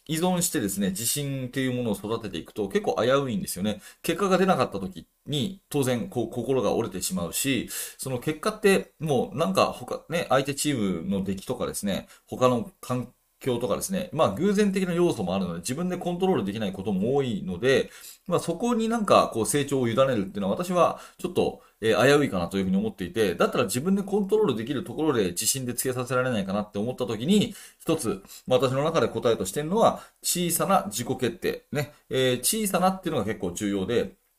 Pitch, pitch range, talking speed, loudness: 145 Hz, 120-190 Hz, 435 characters per minute, -26 LUFS